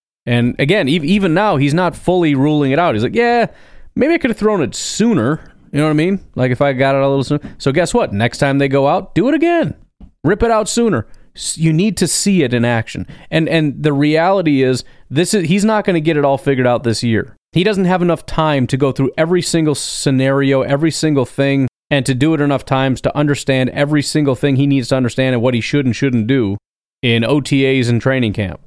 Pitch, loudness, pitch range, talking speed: 145 Hz, -15 LUFS, 135-170 Hz, 240 wpm